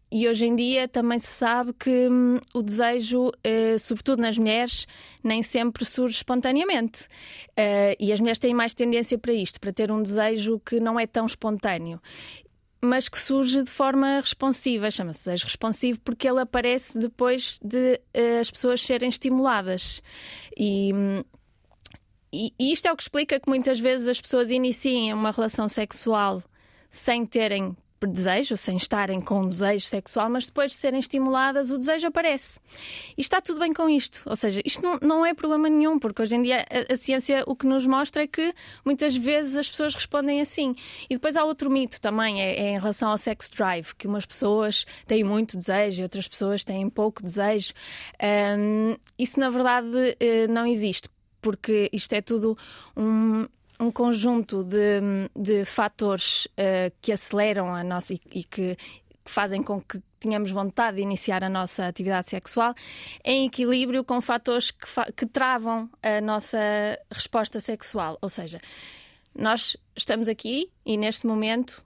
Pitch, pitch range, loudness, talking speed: 230 Hz, 210-255 Hz, -25 LUFS, 170 wpm